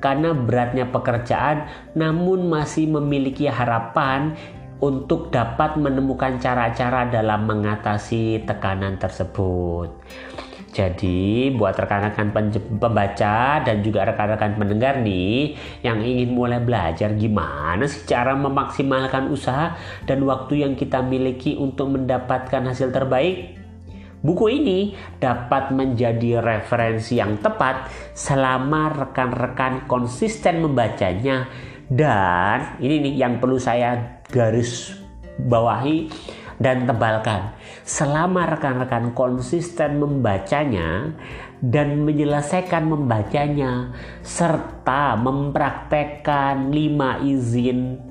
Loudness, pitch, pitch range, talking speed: -21 LUFS, 130 Hz, 110-140 Hz, 90 wpm